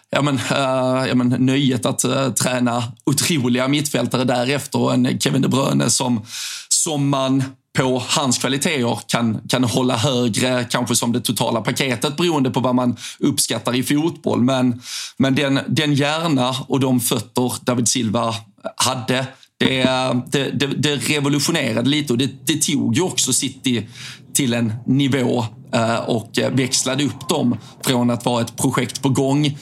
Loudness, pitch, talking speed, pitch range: -19 LUFS, 130 Hz, 155 wpm, 125-140 Hz